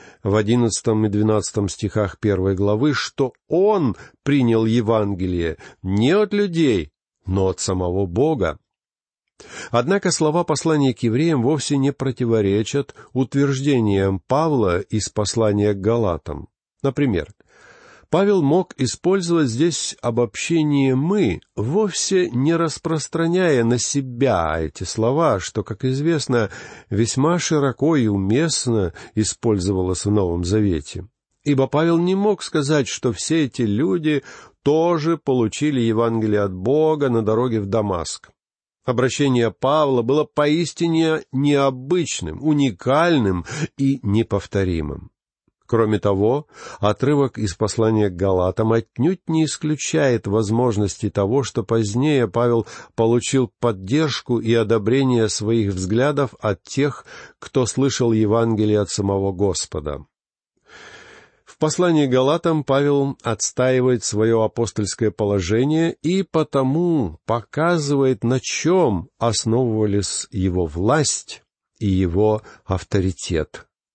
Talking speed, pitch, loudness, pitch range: 105 wpm, 120 Hz, -20 LUFS, 105-145 Hz